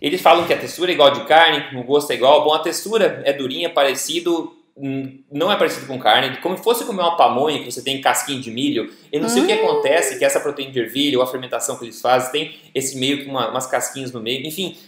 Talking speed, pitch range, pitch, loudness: 260 wpm, 135-180 Hz, 145 Hz, -18 LUFS